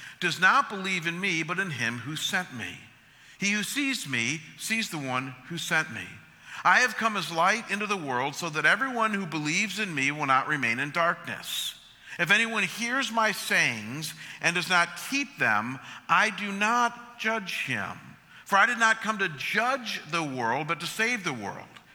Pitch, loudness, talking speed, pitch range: 180 Hz, -26 LUFS, 190 wpm, 145-220 Hz